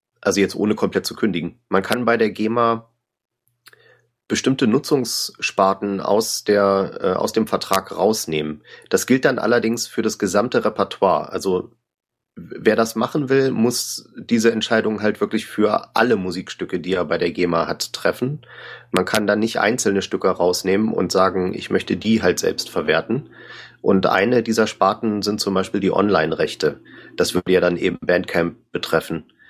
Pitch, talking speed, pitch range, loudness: 110 Hz, 160 wpm, 95-115 Hz, -20 LUFS